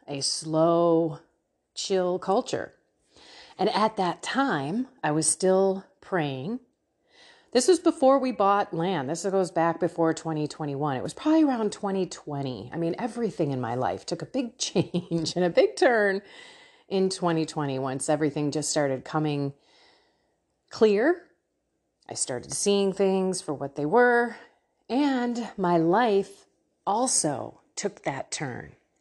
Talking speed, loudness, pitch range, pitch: 135 wpm, -26 LUFS, 155-220 Hz, 180 Hz